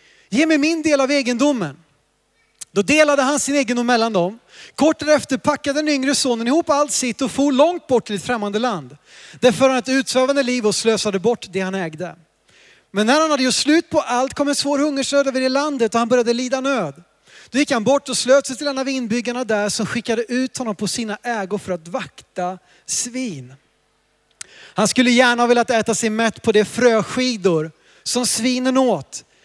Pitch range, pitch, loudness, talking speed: 215-275 Hz, 250 Hz, -18 LUFS, 200 wpm